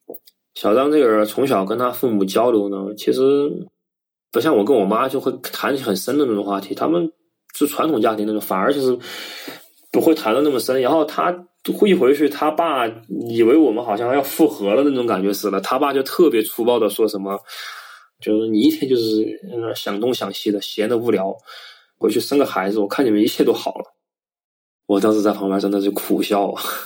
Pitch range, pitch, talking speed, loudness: 105-145 Hz, 115 Hz, 295 characters per minute, -19 LUFS